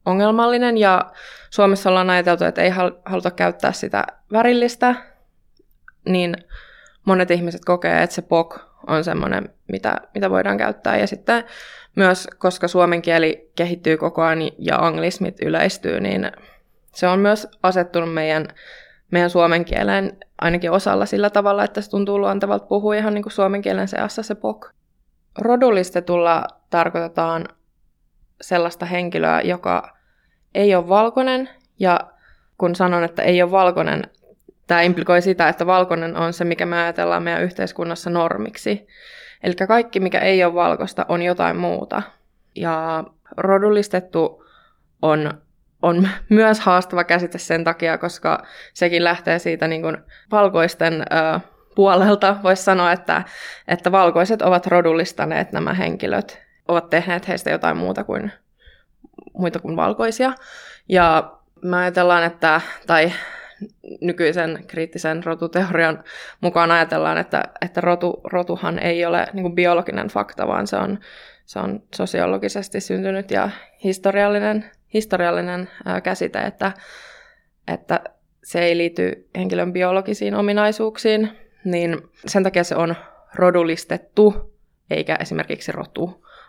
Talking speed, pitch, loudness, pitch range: 125 wpm, 175 Hz, -19 LUFS, 165-195 Hz